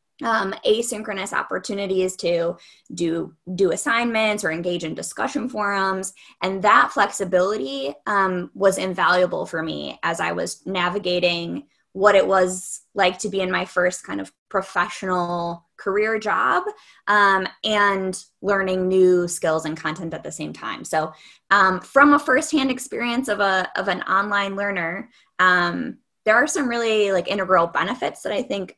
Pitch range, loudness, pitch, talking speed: 180-210 Hz, -21 LUFS, 190 Hz, 150 wpm